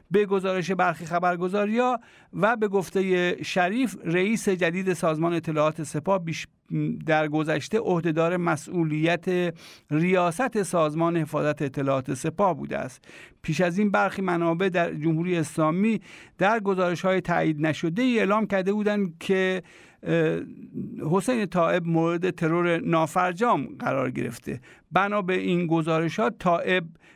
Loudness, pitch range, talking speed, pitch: -25 LUFS, 165-195 Hz, 120 wpm, 180 Hz